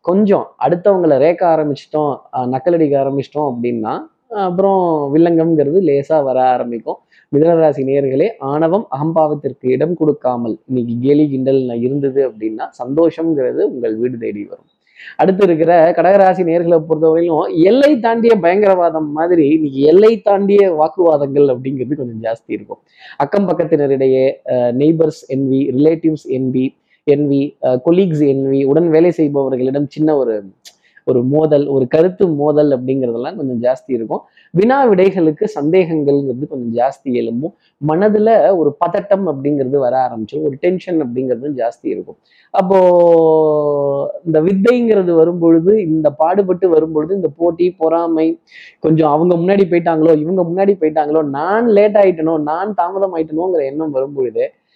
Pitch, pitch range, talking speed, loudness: 155 Hz, 140-175 Hz, 125 wpm, -14 LUFS